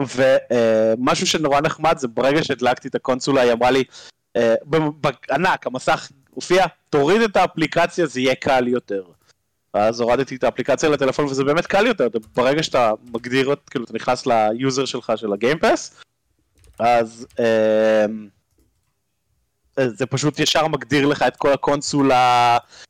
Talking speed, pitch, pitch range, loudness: 135 wpm, 130 Hz, 115-145 Hz, -19 LUFS